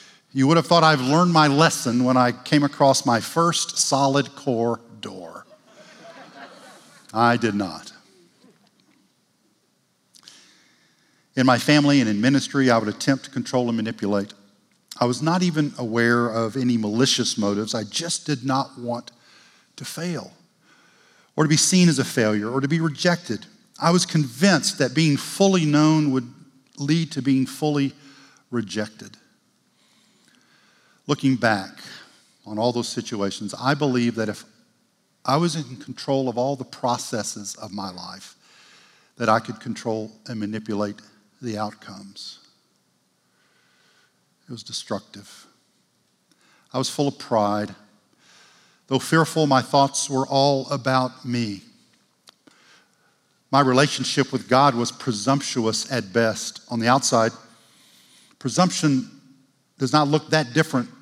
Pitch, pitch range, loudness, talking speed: 130 Hz, 115-145 Hz, -21 LUFS, 135 wpm